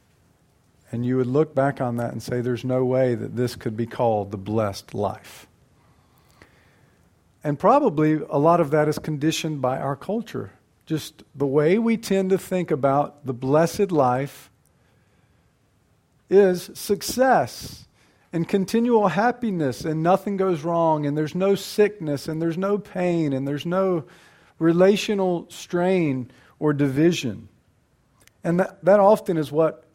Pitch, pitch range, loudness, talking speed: 155 Hz, 130-185 Hz, -22 LUFS, 145 wpm